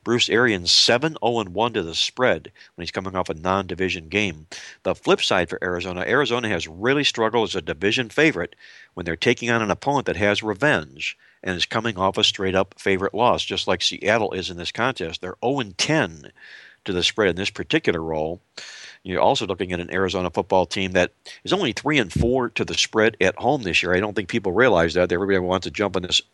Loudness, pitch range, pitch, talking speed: -21 LUFS, 90-110 Hz, 95 Hz, 220 wpm